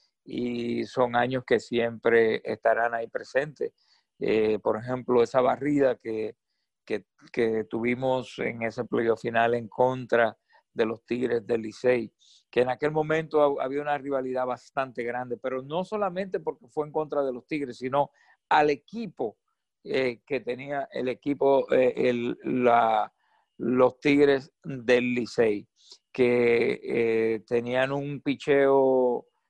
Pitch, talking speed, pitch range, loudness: 125 Hz, 135 wpm, 120-140 Hz, -26 LUFS